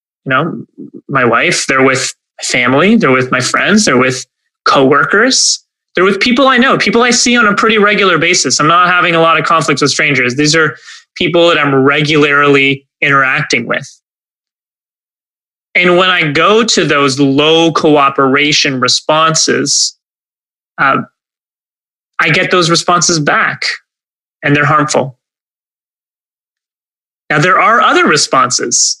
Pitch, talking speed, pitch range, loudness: 155 Hz, 140 wpm, 140-180 Hz, -9 LUFS